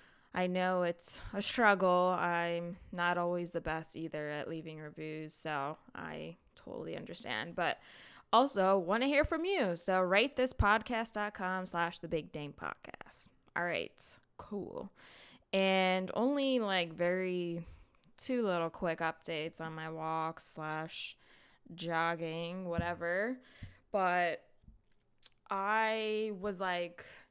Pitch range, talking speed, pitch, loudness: 165-200 Hz, 120 wpm, 175 Hz, -35 LUFS